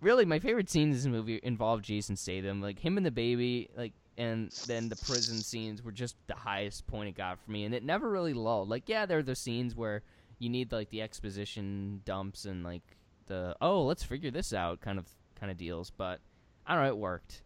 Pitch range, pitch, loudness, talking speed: 100-120 Hz, 110 Hz, -35 LUFS, 230 wpm